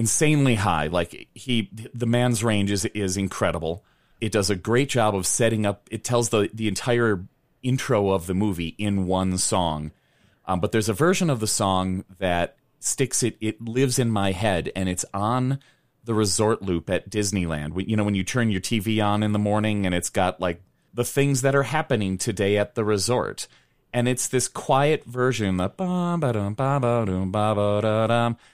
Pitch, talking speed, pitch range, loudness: 110 Hz, 175 wpm, 100-125 Hz, -23 LUFS